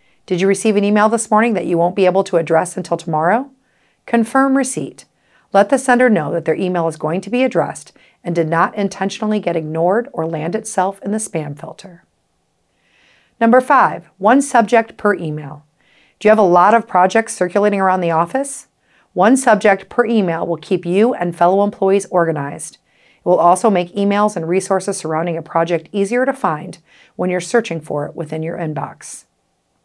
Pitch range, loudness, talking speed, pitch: 170-220 Hz, -16 LUFS, 185 wpm, 190 Hz